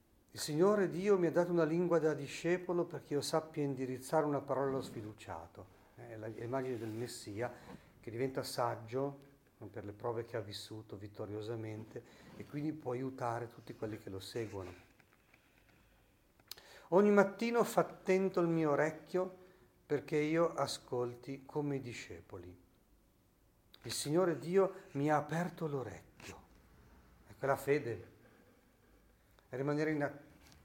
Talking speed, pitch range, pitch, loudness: 135 wpm, 110-155 Hz, 135 Hz, -37 LUFS